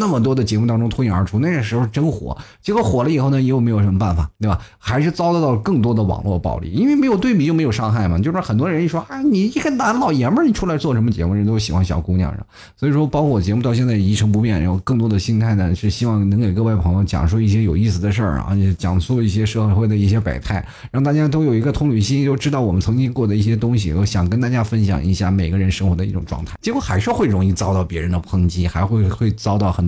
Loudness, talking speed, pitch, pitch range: -18 LUFS, 415 characters per minute, 110 Hz, 95-130 Hz